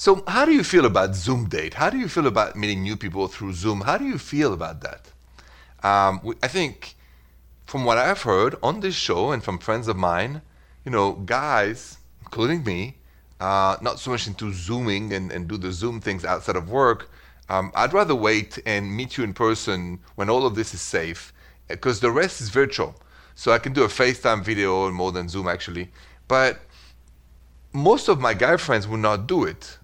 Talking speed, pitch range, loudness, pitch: 205 wpm, 85-115 Hz, -22 LUFS, 100 Hz